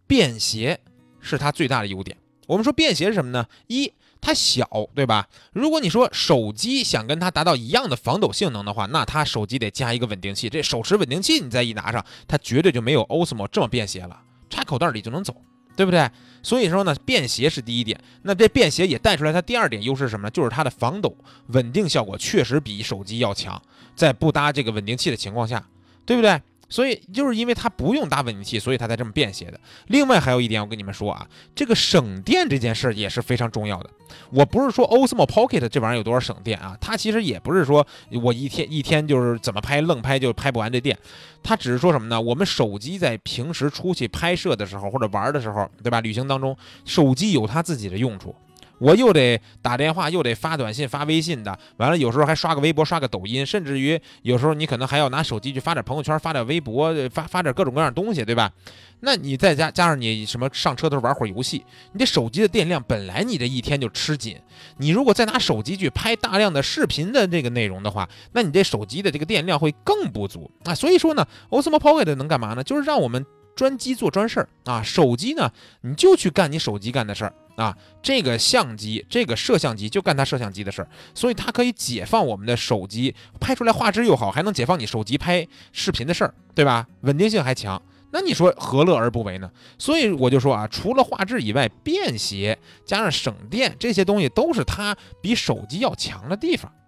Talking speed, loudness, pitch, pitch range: 350 characters per minute, -21 LUFS, 140 Hz, 115-180 Hz